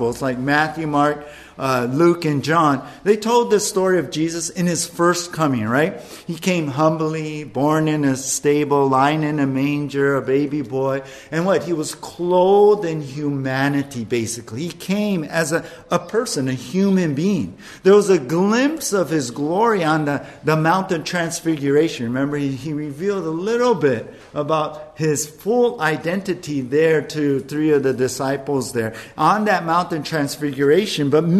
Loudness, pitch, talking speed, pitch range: -19 LUFS, 155 Hz, 160 wpm, 140-175 Hz